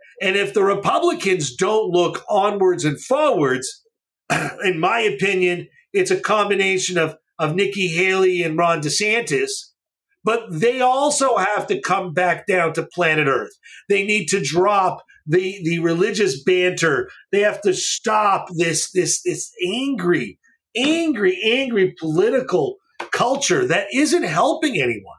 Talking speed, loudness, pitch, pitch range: 135 wpm, -19 LUFS, 200 Hz, 180-270 Hz